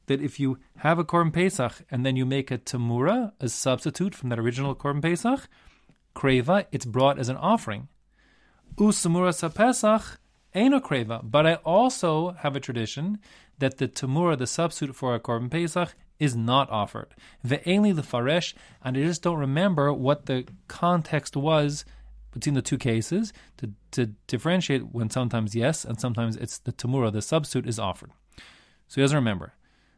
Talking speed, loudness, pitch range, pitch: 170 wpm, -26 LUFS, 125-170 Hz, 140 Hz